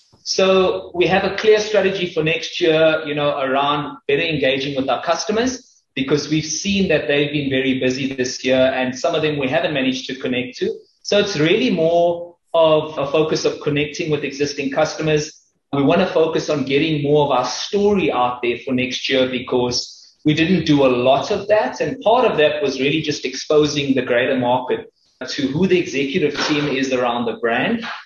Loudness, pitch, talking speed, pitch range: -18 LUFS, 150 Hz, 195 wpm, 135-170 Hz